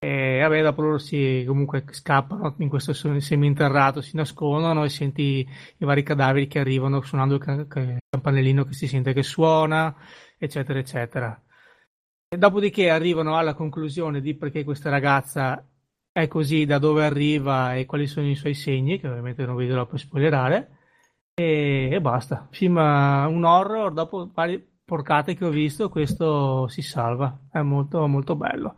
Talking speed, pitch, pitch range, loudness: 165 wpm, 145 Hz, 135-155 Hz, -23 LUFS